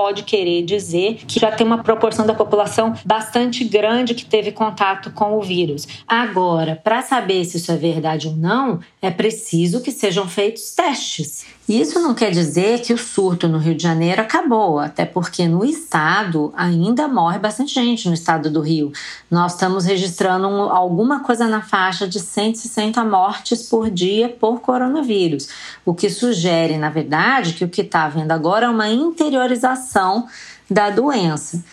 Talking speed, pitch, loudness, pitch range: 165 wpm, 205 Hz, -18 LUFS, 175-230 Hz